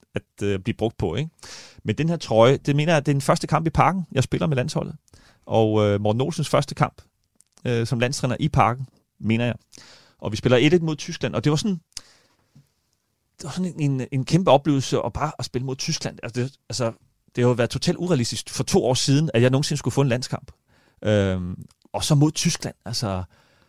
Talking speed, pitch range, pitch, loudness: 220 wpm, 115-155 Hz, 135 Hz, -22 LUFS